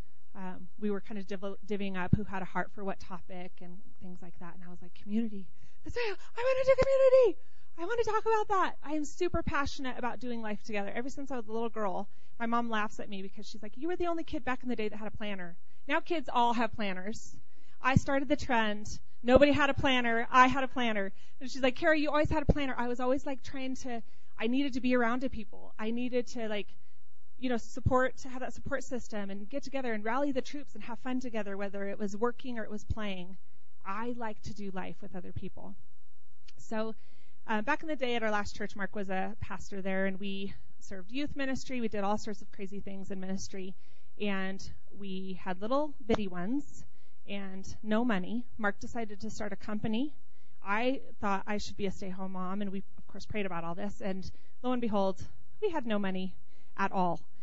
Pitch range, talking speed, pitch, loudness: 195-255 Hz, 230 wpm, 215 Hz, -33 LUFS